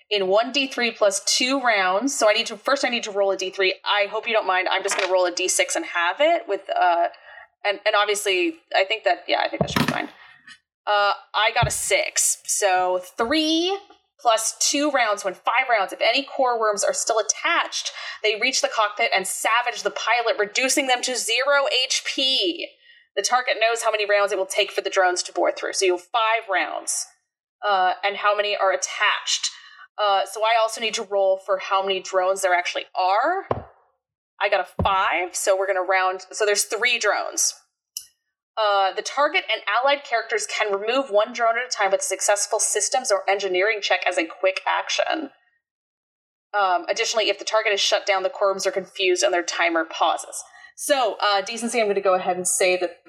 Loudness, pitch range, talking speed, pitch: -21 LUFS, 195-255 Hz, 205 wpm, 210 Hz